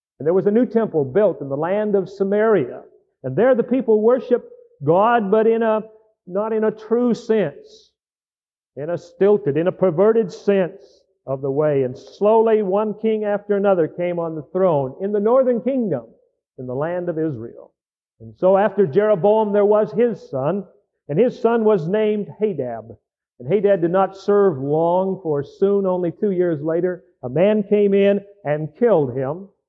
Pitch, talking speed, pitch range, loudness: 200 Hz, 180 wpm, 170-220 Hz, -19 LUFS